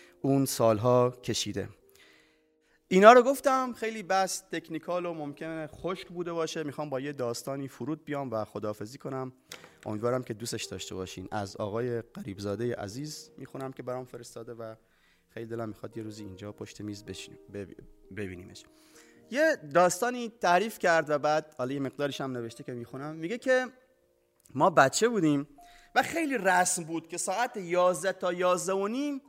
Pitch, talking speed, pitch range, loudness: 145 Hz, 155 wpm, 115-180 Hz, -29 LUFS